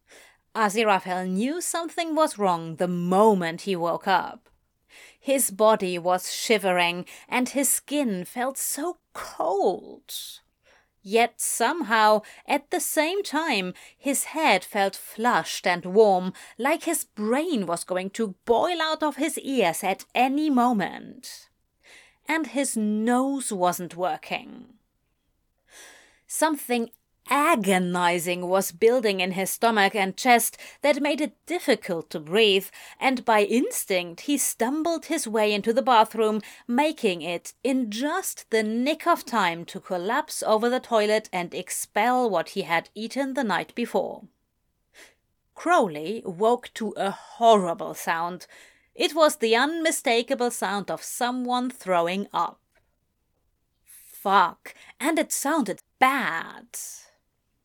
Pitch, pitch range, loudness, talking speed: 230 Hz, 190-275 Hz, -24 LUFS, 125 wpm